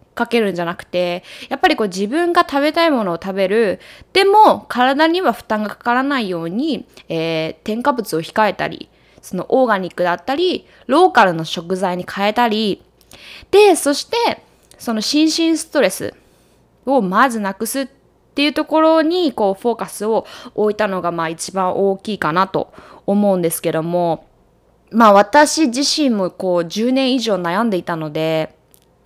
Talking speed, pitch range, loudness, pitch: 315 characters per minute, 180-280 Hz, -16 LUFS, 215 Hz